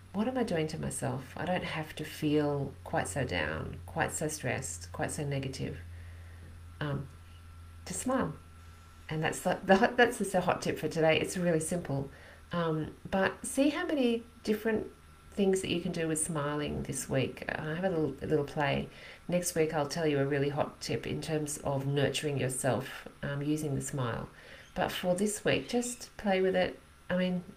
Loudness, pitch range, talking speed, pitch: -32 LUFS, 130-180 Hz, 185 wpm, 155 Hz